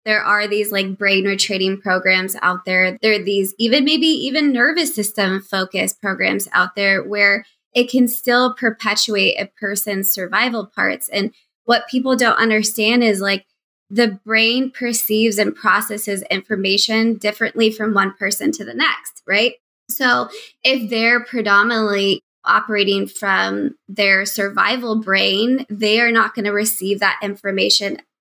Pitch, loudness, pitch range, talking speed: 210 Hz, -17 LUFS, 195-235 Hz, 145 wpm